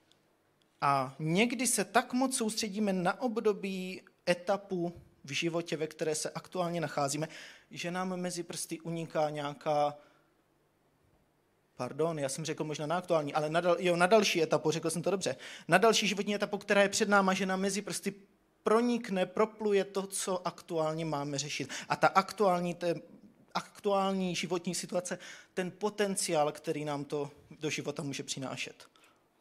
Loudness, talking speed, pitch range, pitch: -32 LUFS, 155 wpm, 155-195 Hz, 175 Hz